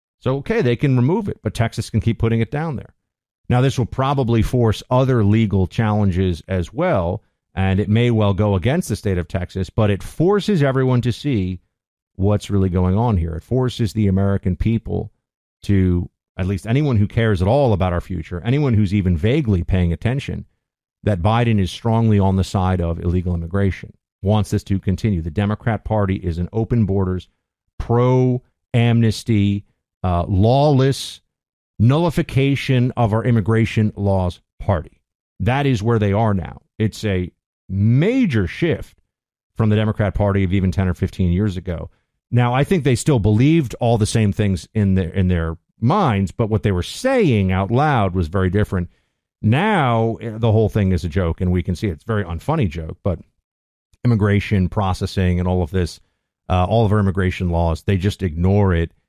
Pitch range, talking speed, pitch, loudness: 95-115 Hz, 180 wpm, 105 Hz, -19 LUFS